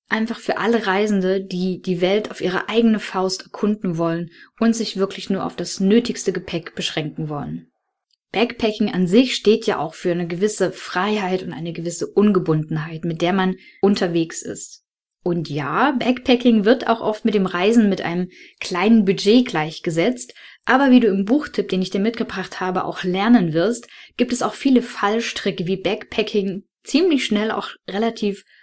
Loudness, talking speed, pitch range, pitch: -20 LUFS, 170 wpm, 180-225 Hz, 200 Hz